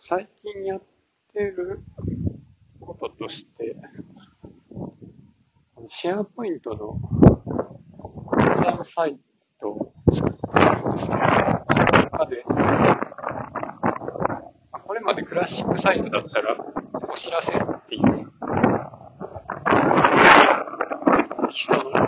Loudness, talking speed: -21 LUFS, 170 characters per minute